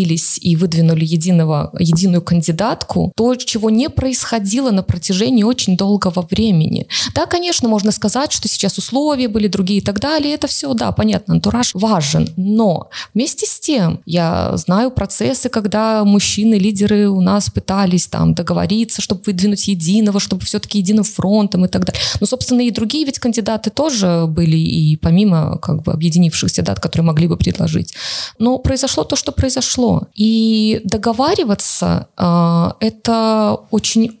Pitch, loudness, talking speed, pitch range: 205 Hz, -15 LUFS, 150 wpm, 175-230 Hz